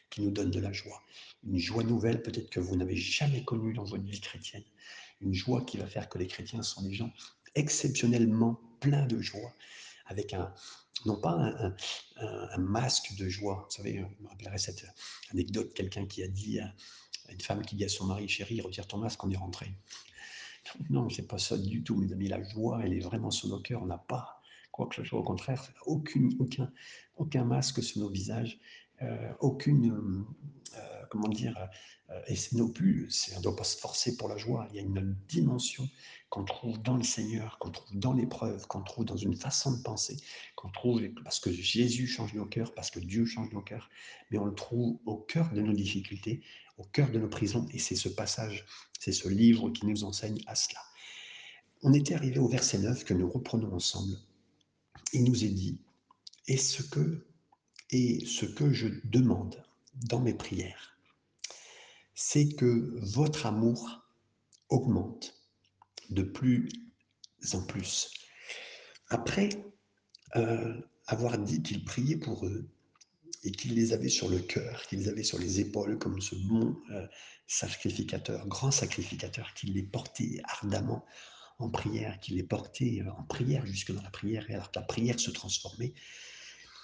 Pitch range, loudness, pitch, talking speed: 100-125 Hz, -33 LUFS, 110 Hz, 185 wpm